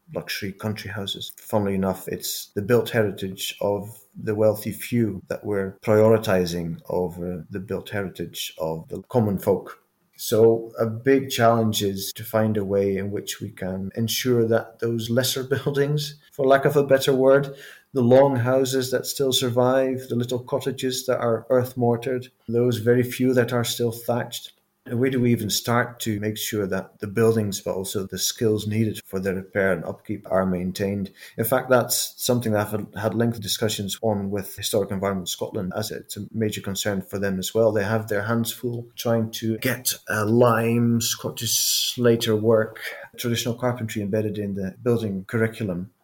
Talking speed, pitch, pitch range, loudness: 175 wpm, 110 Hz, 100-120 Hz, -23 LUFS